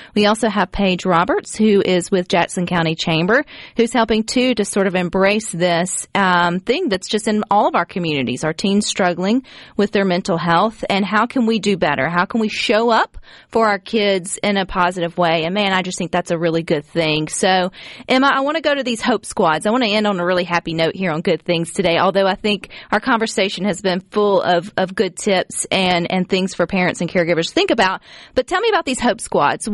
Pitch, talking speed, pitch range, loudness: 190 Hz, 235 wpm, 175-215 Hz, -17 LUFS